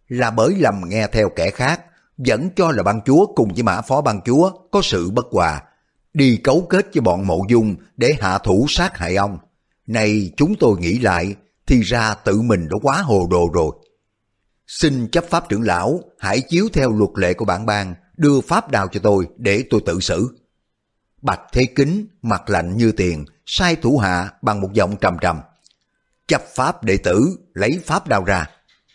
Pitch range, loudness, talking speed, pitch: 95-135 Hz, -18 LUFS, 195 wpm, 110 Hz